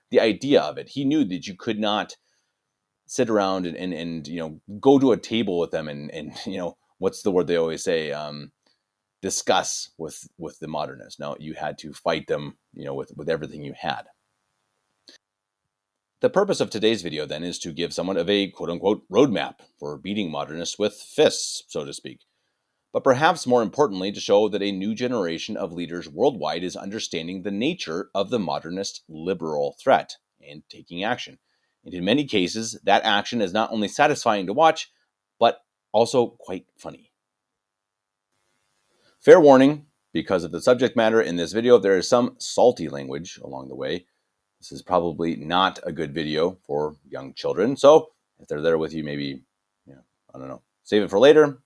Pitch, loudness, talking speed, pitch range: 95 Hz, -23 LUFS, 185 wpm, 80-110 Hz